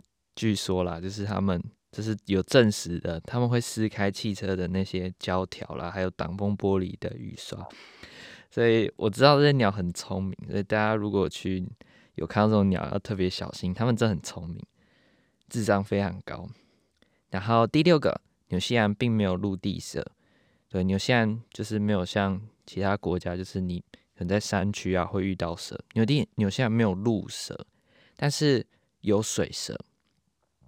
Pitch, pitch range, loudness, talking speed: 100 Hz, 95-110 Hz, -27 LUFS, 255 characters per minute